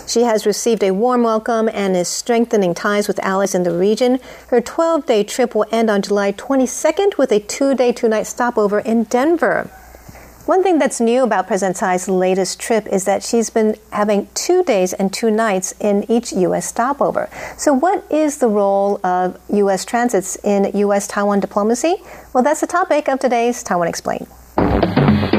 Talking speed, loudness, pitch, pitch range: 180 wpm, -17 LUFS, 225 Hz, 200-250 Hz